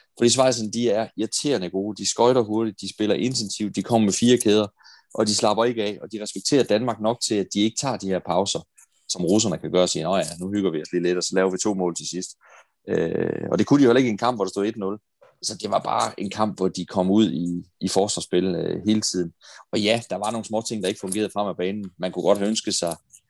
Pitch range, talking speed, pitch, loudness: 95-110 Hz, 275 wpm, 105 Hz, -23 LUFS